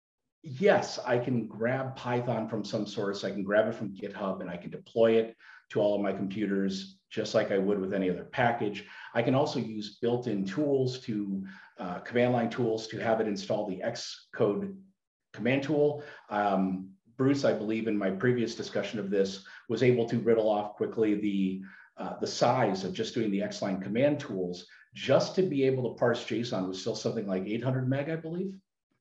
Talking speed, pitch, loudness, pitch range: 190 wpm, 110 Hz, -30 LUFS, 100-125 Hz